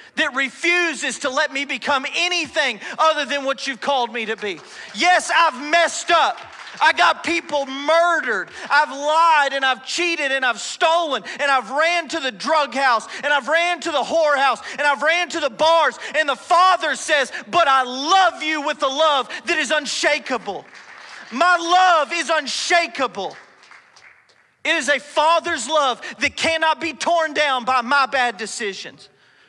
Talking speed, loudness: 165 wpm, -18 LUFS